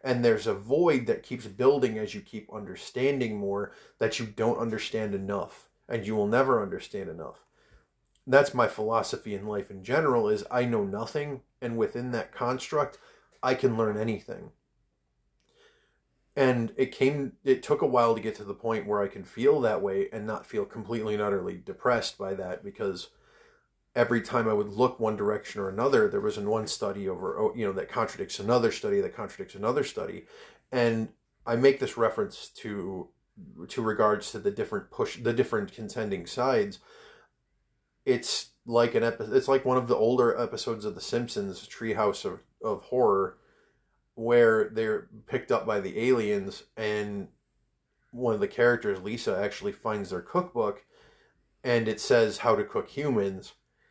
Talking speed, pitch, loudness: 170 wpm, 120 Hz, -28 LUFS